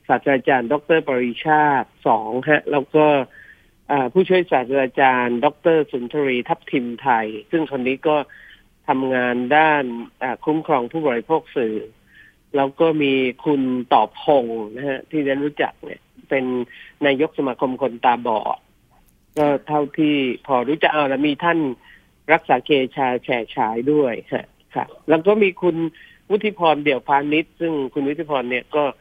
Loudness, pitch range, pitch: -20 LUFS, 130-155 Hz, 145 Hz